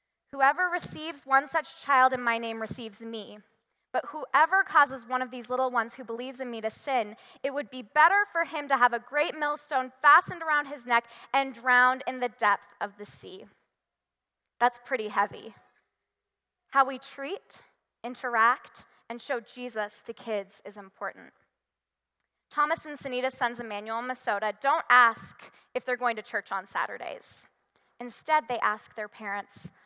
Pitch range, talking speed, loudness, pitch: 225-275 Hz, 165 wpm, -27 LUFS, 250 Hz